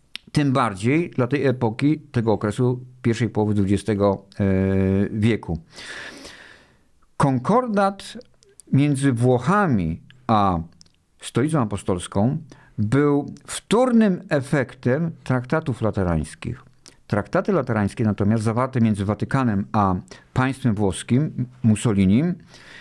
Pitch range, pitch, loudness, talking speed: 105-145 Hz, 125 Hz, -22 LUFS, 85 wpm